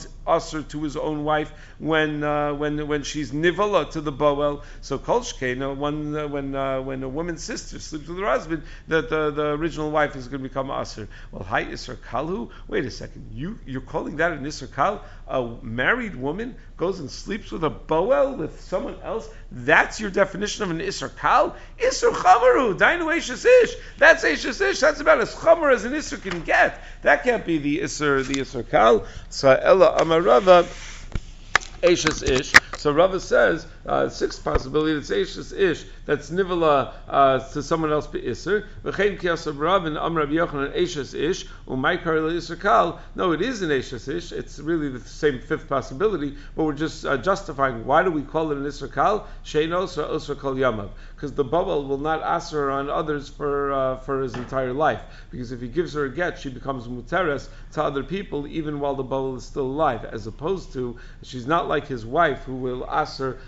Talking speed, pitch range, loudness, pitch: 175 wpm, 135-170 Hz, -23 LUFS, 150 Hz